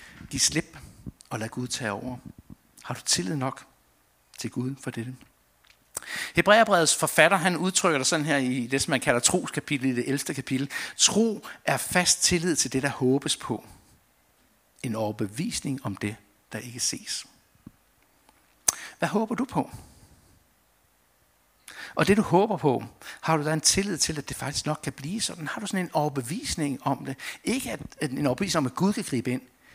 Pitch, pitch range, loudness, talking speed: 135 Hz, 110-160 Hz, -26 LUFS, 175 wpm